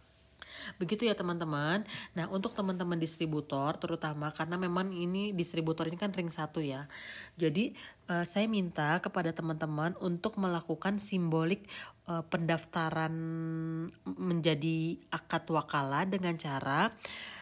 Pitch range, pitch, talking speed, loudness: 160-185 Hz, 170 Hz, 115 wpm, -33 LUFS